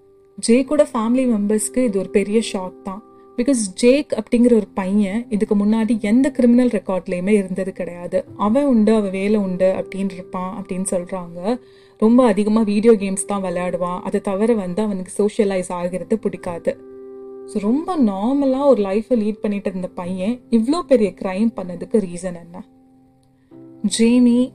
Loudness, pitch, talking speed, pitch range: -19 LUFS, 205 Hz, 140 wpm, 185-235 Hz